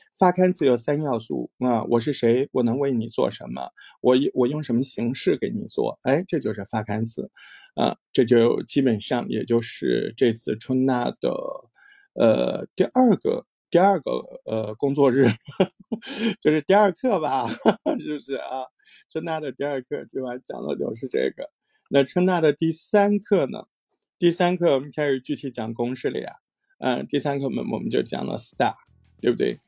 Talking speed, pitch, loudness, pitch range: 265 characters per minute, 140 Hz, -23 LUFS, 120-175 Hz